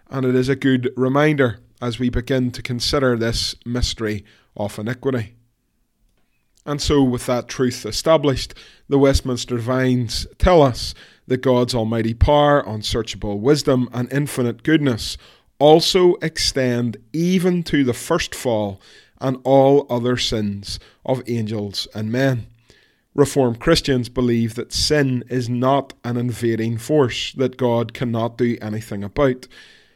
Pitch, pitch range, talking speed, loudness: 125 Hz, 115-135 Hz, 130 wpm, -19 LUFS